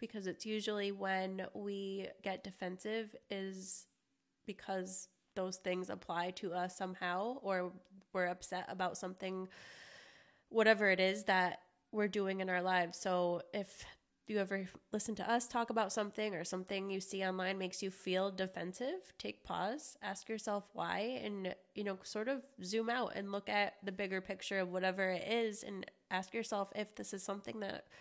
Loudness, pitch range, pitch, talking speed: -39 LUFS, 185-210 Hz, 195 Hz, 165 wpm